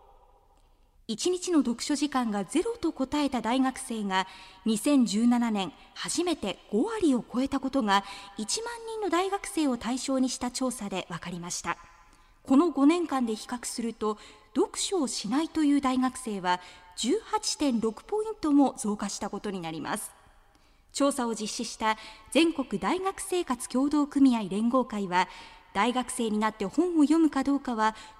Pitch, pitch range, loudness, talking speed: 250 Hz, 210-295 Hz, -28 LUFS, 270 characters per minute